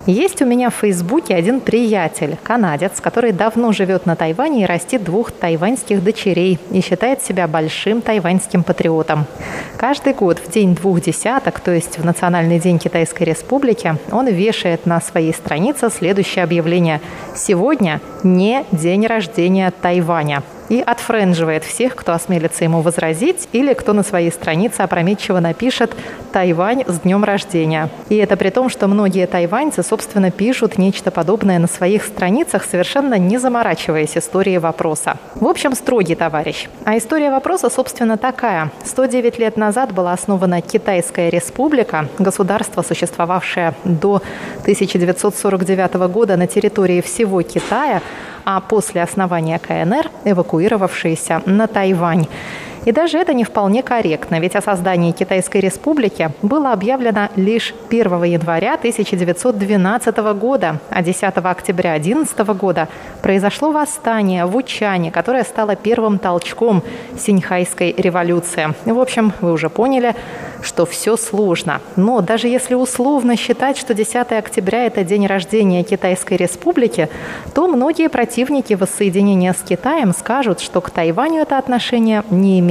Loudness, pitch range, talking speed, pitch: -16 LUFS, 175-230 Hz, 135 wpm, 195 Hz